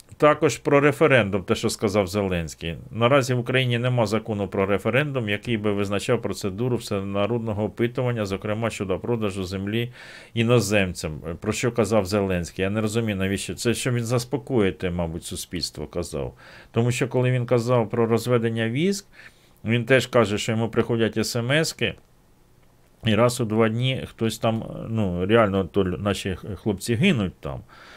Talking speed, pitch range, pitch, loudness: 150 wpm, 100-120 Hz, 110 Hz, -23 LUFS